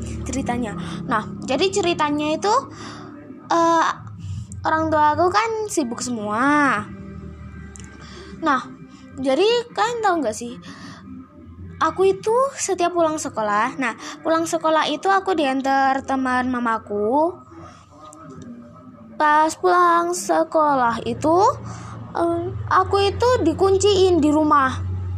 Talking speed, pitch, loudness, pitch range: 100 wpm, 310 Hz, -20 LUFS, 245-365 Hz